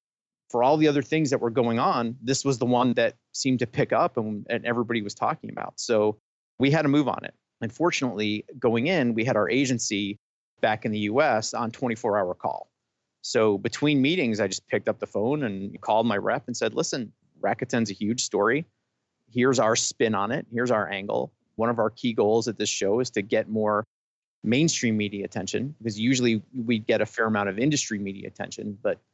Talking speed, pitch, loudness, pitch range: 210 wpm, 115 Hz, -25 LUFS, 105-130 Hz